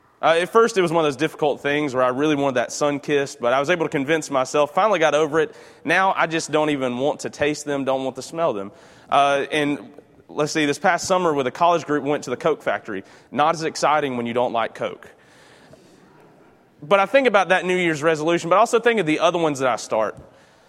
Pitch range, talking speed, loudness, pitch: 140-170 Hz, 240 wpm, -20 LUFS, 150 Hz